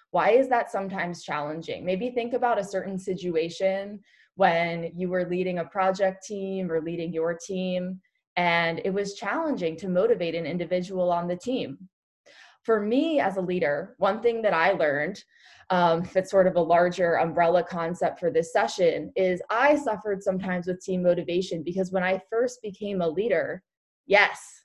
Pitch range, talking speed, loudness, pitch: 175-200 Hz, 170 wpm, -26 LUFS, 185 Hz